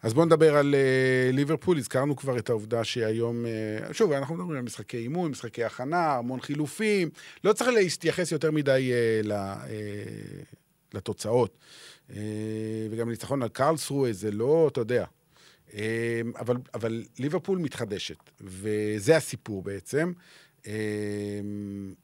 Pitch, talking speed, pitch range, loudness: 120 Hz, 135 wpm, 110-150 Hz, -28 LUFS